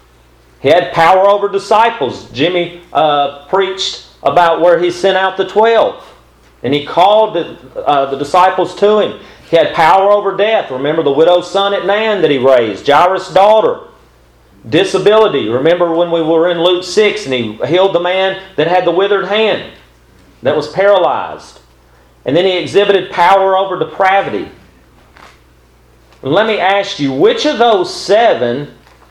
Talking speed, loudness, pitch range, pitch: 160 wpm, -11 LUFS, 145-195 Hz, 175 Hz